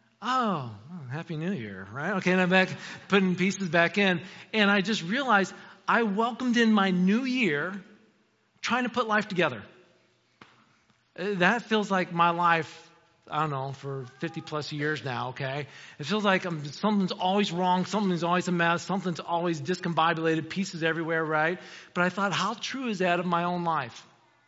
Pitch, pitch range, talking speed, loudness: 180 Hz, 160-200 Hz, 170 wpm, -27 LUFS